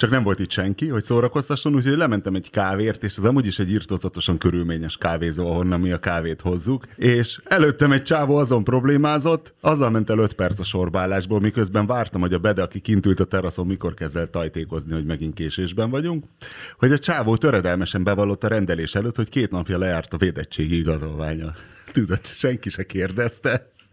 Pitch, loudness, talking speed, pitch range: 100 Hz, -22 LUFS, 180 wpm, 90-125 Hz